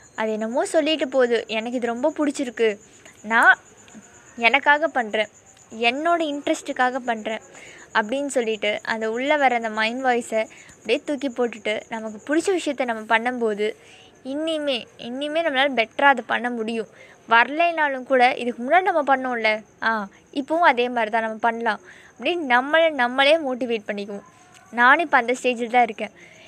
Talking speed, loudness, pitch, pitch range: 140 wpm, -21 LUFS, 245 Hz, 225-285 Hz